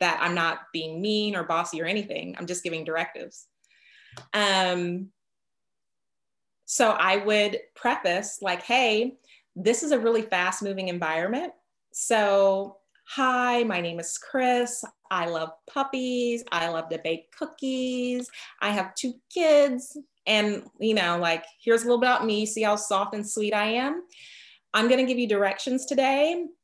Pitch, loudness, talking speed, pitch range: 215 Hz, -25 LUFS, 155 wpm, 180-255 Hz